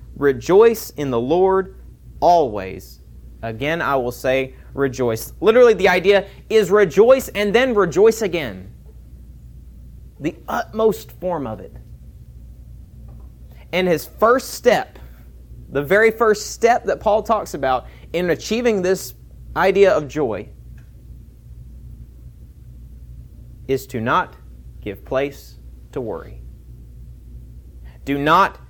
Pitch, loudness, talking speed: 130 Hz, -18 LUFS, 105 wpm